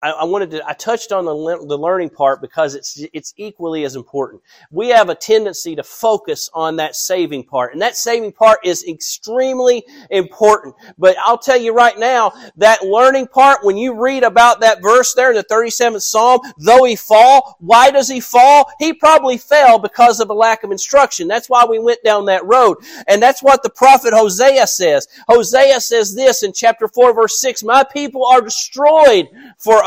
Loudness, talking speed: -12 LUFS, 195 wpm